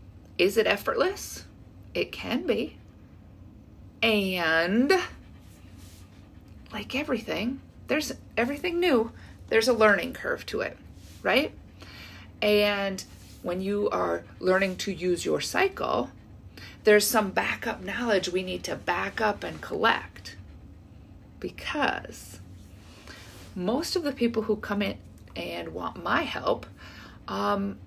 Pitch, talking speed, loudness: 165 Hz, 110 wpm, -27 LUFS